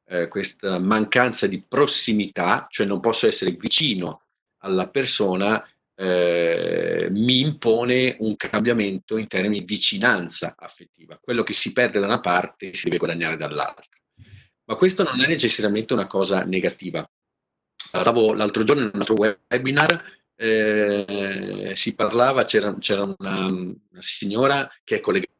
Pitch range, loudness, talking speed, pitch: 95-120 Hz, -21 LUFS, 130 wpm, 105 Hz